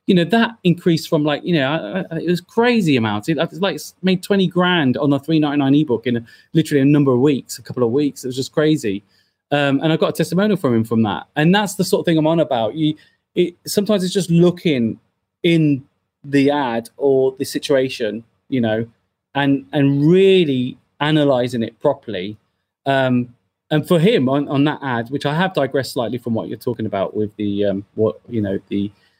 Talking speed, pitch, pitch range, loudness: 210 wpm, 140 Hz, 115-165 Hz, -18 LUFS